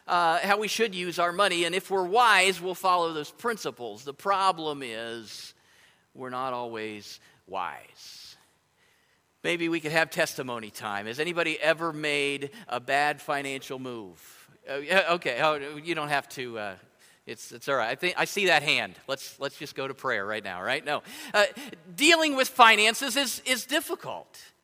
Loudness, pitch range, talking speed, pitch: -26 LUFS, 135-195 Hz, 175 wpm, 165 Hz